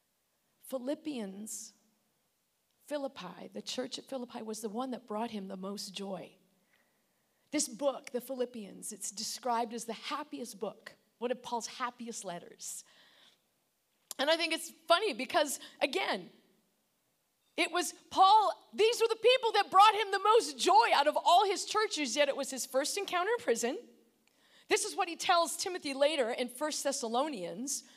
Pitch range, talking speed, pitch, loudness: 235-345 Hz, 155 wpm, 275 Hz, -32 LUFS